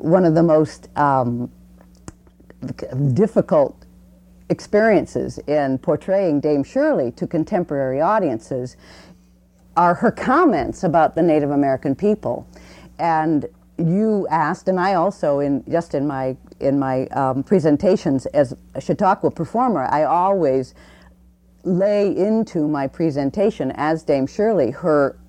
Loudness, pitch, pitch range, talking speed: -19 LUFS, 150 Hz, 130-185 Hz, 120 wpm